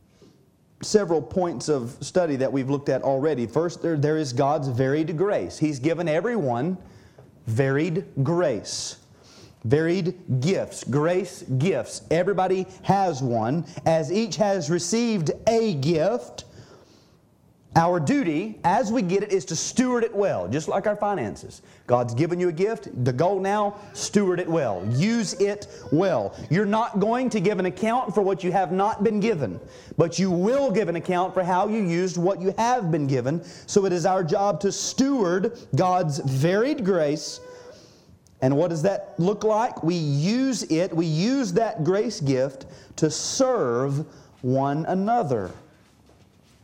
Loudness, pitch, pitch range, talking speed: -24 LUFS, 180 Hz, 150-205 Hz, 155 wpm